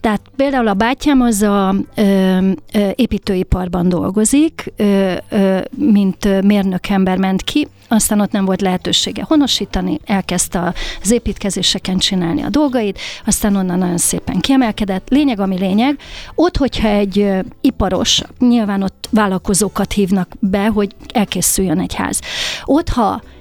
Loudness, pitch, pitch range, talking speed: -15 LUFS, 200 Hz, 190-225 Hz, 135 wpm